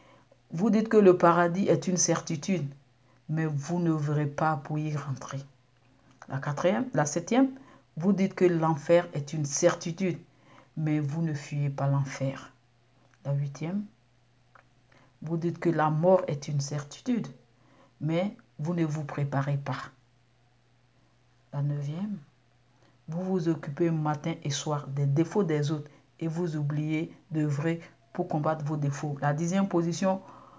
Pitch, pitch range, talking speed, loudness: 150 Hz, 140-170 Hz, 145 wpm, -29 LUFS